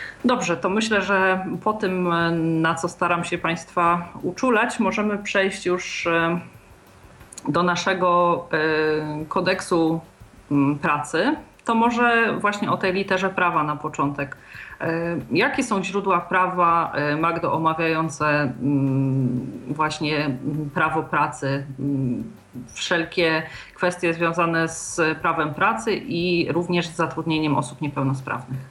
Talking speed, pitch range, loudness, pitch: 100 wpm, 150-185 Hz, -22 LUFS, 165 Hz